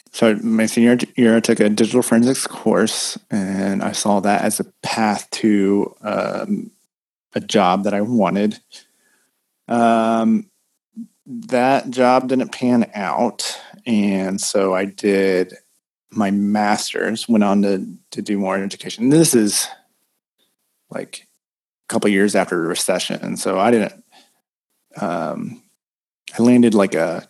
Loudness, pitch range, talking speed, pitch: -18 LUFS, 100-120 Hz, 135 wpm, 110 Hz